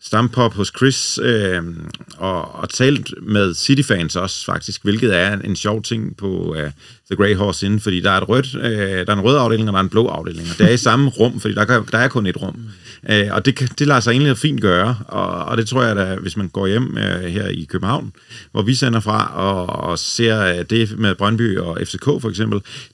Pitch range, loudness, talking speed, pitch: 95-120 Hz, -17 LUFS, 240 wpm, 105 Hz